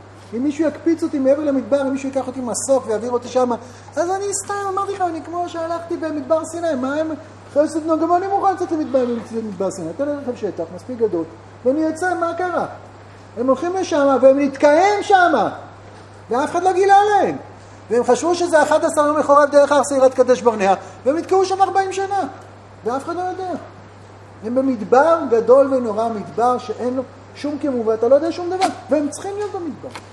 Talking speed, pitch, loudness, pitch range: 185 wpm, 290 Hz, -18 LUFS, 245-345 Hz